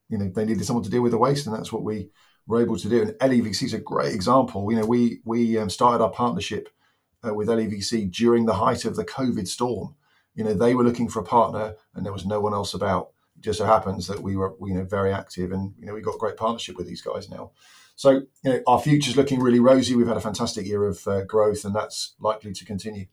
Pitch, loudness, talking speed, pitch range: 110 Hz, -23 LUFS, 265 wpm, 100-120 Hz